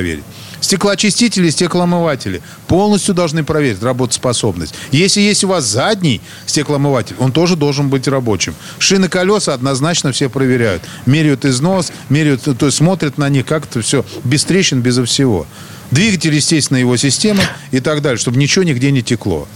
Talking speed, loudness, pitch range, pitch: 155 wpm, -13 LUFS, 130-170 Hz, 145 Hz